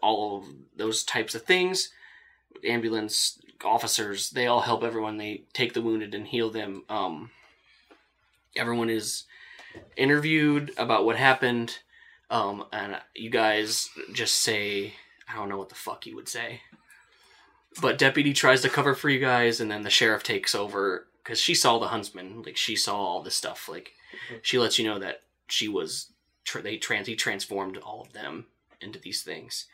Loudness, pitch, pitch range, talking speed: -26 LUFS, 115 Hz, 105-135 Hz, 170 wpm